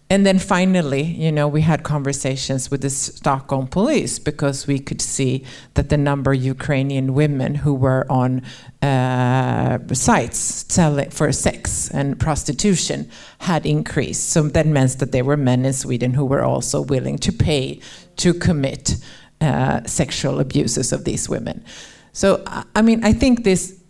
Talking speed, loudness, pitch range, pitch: 160 wpm, -19 LUFS, 130-155 Hz, 140 Hz